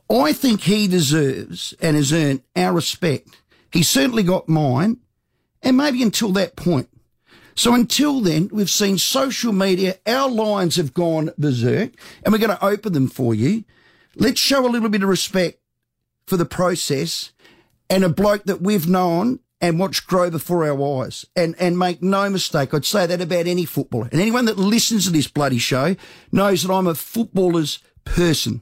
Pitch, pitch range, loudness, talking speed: 180 Hz, 160-210 Hz, -19 LUFS, 180 wpm